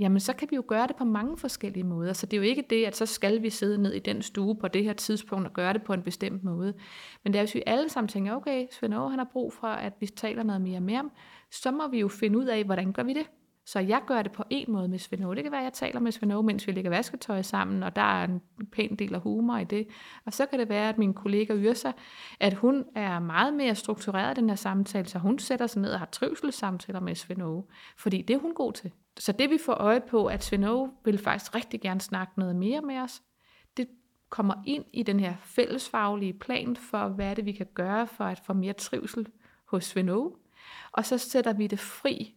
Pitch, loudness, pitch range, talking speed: 215 Hz, -29 LUFS, 195-245 Hz, 255 wpm